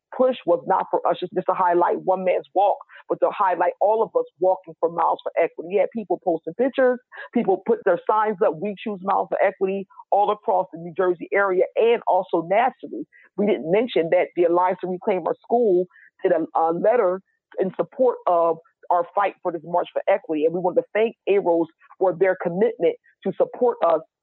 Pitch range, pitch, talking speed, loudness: 175-225 Hz, 190 Hz, 205 wpm, -22 LUFS